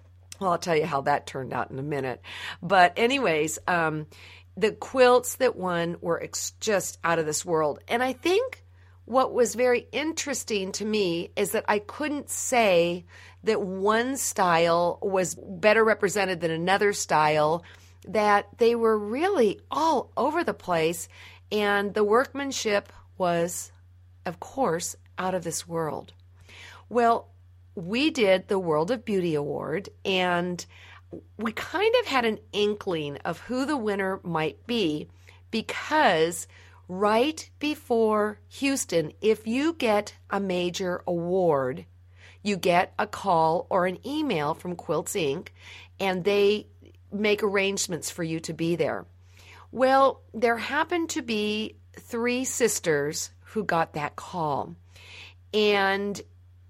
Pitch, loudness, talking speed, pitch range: 185 Hz, -26 LUFS, 135 wpm, 140-220 Hz